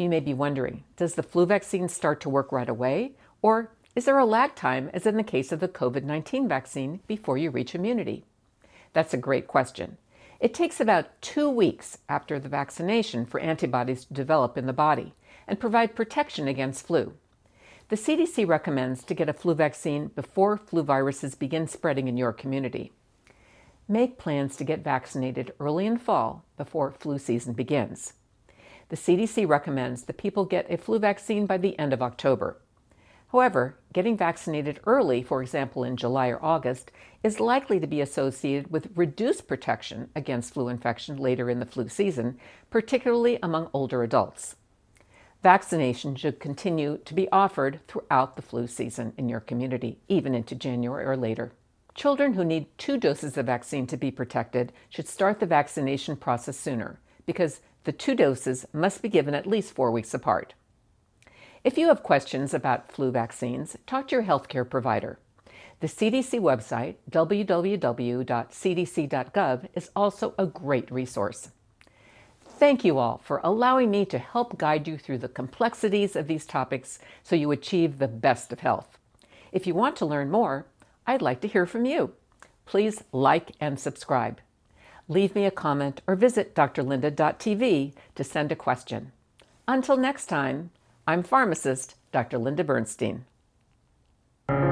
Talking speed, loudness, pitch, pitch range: 160 wpm, -27 LUFS, 150 Hz, 130-195 Hz